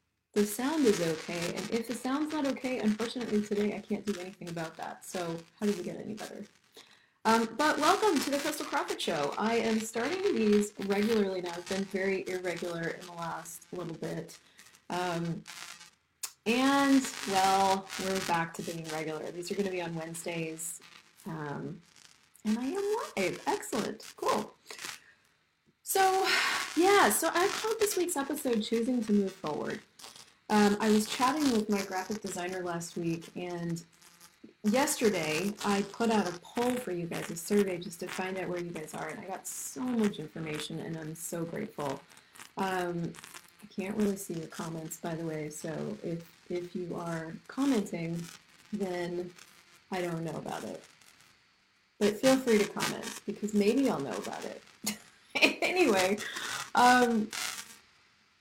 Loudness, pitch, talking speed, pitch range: -31 LUFS, 200 Hz, 160 wpm, 175-230 Hz